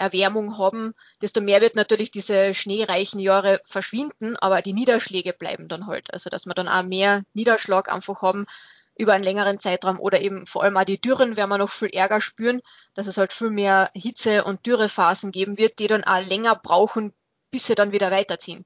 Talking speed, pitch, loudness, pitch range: 200 wpm, 200 Hz, -21 LUFS, 190-220 Hz